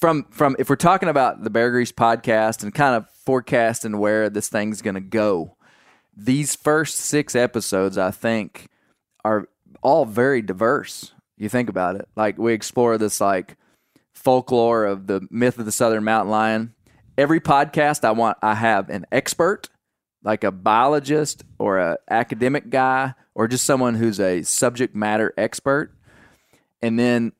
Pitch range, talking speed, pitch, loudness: 110-130 Hz, 160 wpm, 115 Hz, -20 LUFS